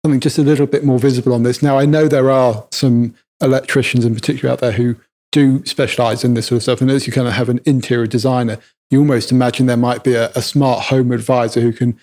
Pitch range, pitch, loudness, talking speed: 120-135 Hz, 125 Hz, -15 LUFS, 250 wpm